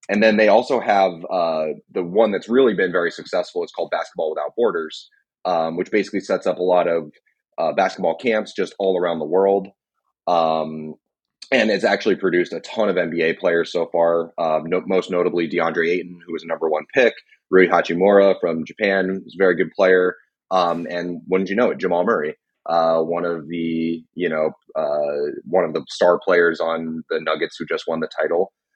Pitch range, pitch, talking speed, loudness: 80-95 Hz, 85 Hz, 200 wpm, -20 LUFS